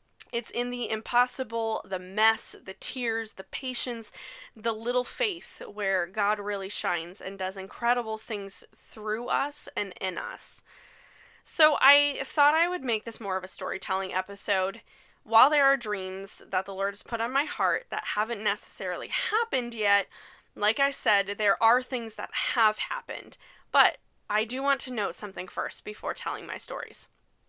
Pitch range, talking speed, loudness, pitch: 200-260 Hz, 165 wpm, -28 LUFS, 225 Hz